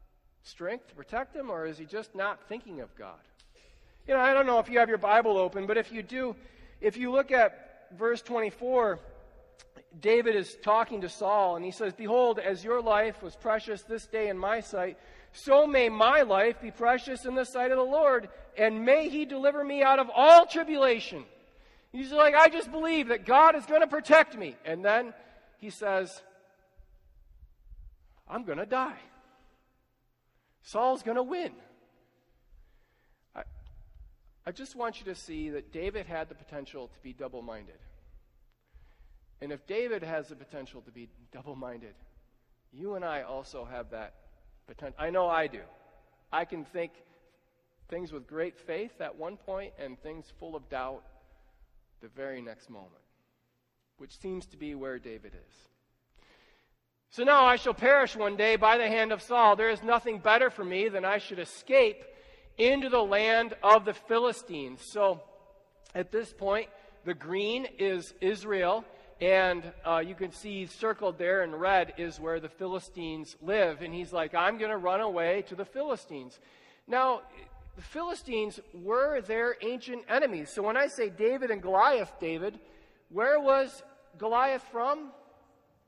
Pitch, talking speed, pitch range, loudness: 210 Hz, 170 wpm, 170-250 Hz, -27 LUFS